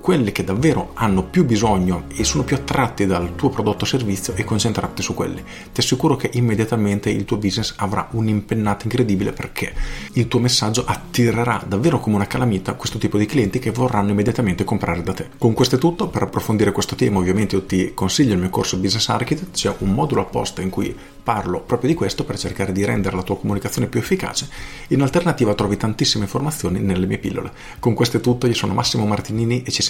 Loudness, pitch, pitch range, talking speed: -20 LUFS, 105 Hz, 100-120 Hz, 210 wpm